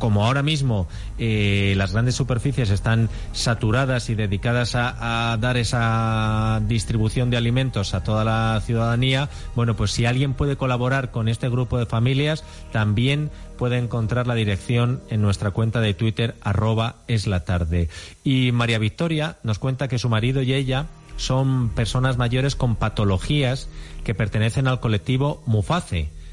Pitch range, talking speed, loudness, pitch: 110-130 Hz, 150 wpm, -22 LUFS, 115 Hz